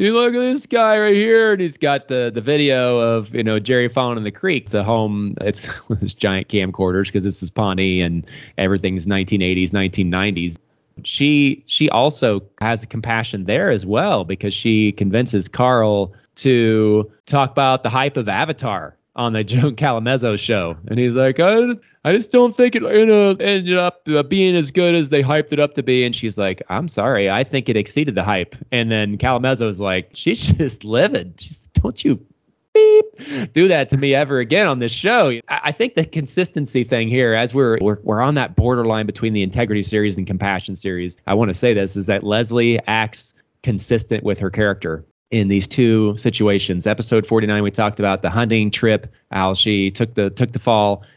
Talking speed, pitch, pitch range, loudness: 195 wpm, 115 Hz, 100-140 Hz, -17 LUFS